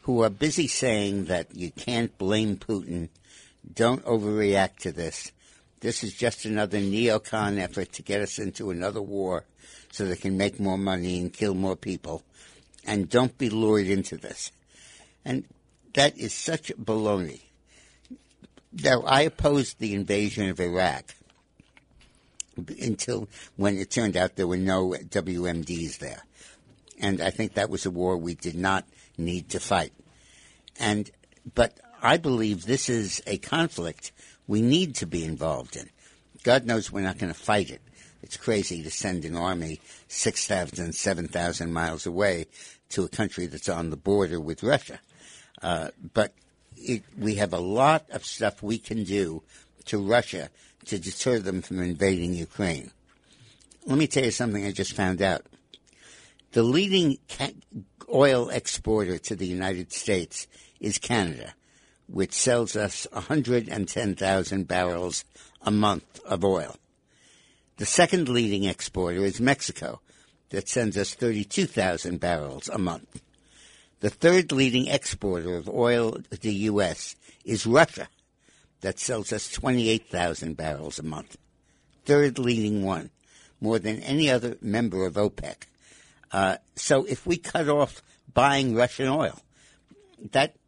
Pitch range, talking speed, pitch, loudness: 90-115 Hz, 145 wpm, 100 Hz, -26 LUFS